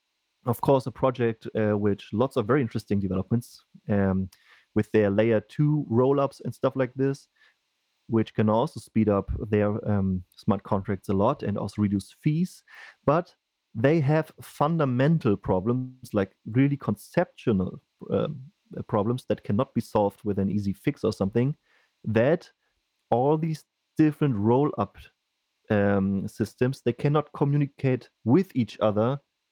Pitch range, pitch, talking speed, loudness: 105-140 Hz, 115 Hz, 140 wpm, -26 LUFS